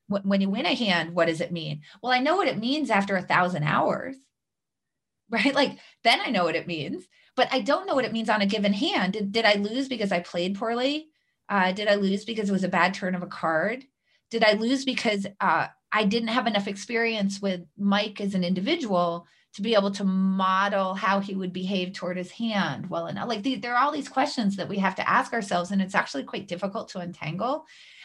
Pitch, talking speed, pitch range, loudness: 200 Hz, 230 wpm, 185-235 Hz, -25 LUFS